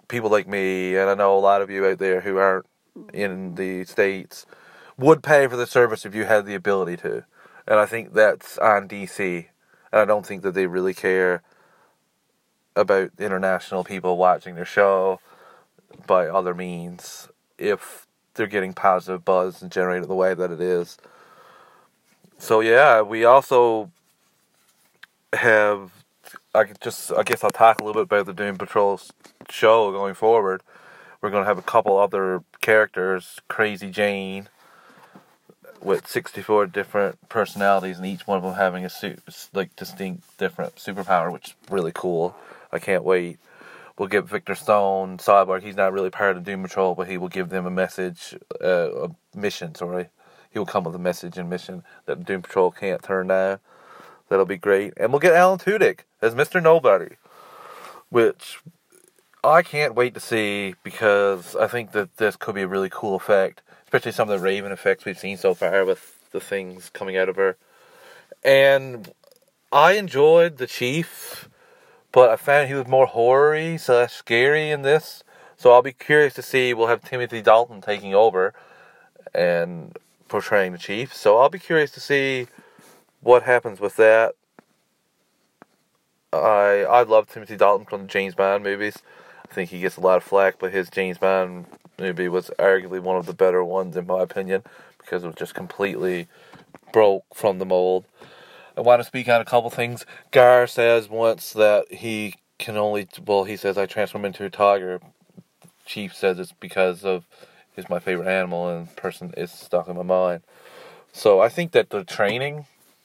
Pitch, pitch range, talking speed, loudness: 100 Hz, 95-120 Hz, 175 wpm, -21 LUFS